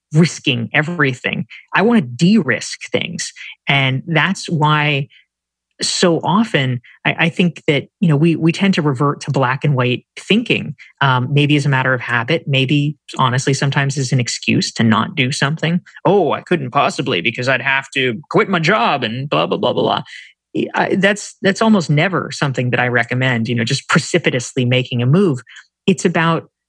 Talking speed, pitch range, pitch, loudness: 180 wpm, 130-165 Hz, 145 Hz, -16 LUFS